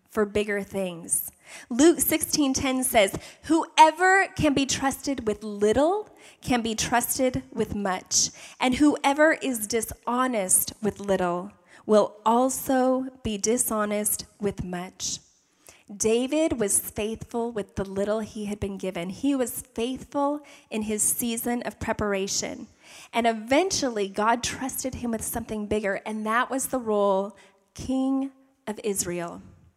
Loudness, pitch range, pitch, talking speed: -25 LUFS, 205-265 Hz, 230 Hz, 125 wpm